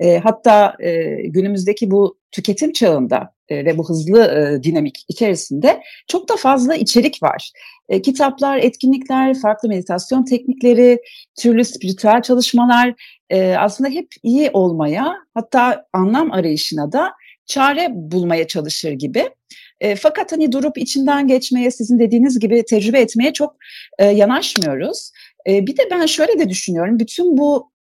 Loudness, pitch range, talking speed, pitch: -15 LUFS, 195-275 Hz, 120 wpm, 240 Hz